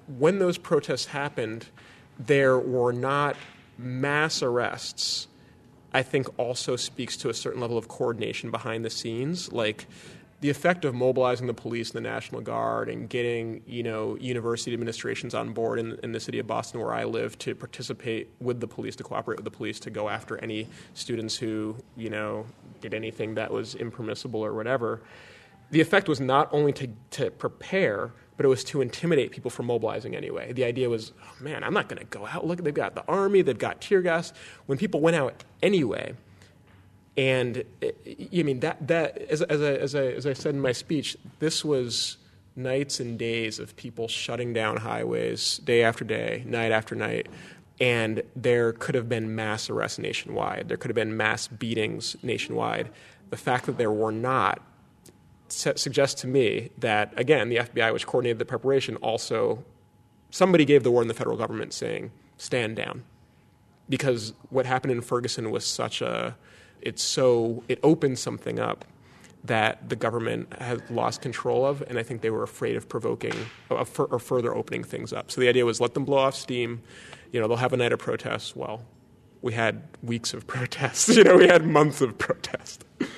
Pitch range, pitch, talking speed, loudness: 115-140 Hz, 125 Hz, 185 wpm, -26 LUFS